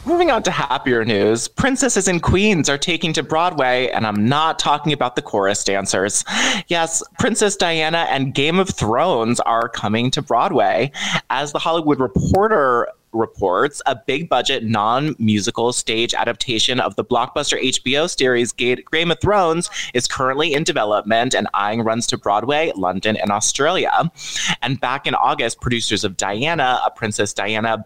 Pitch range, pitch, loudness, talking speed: 115-165 Hz, 135 Hz, -18 LUFS, 155 wpm